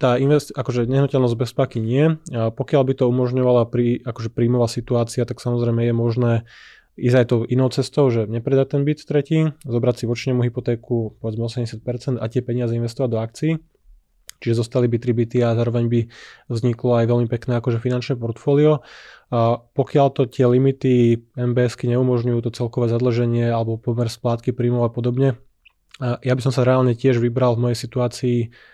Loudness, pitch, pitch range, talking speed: -20 LUFS, 120 Hz, 120-130 Hz, 170 wpm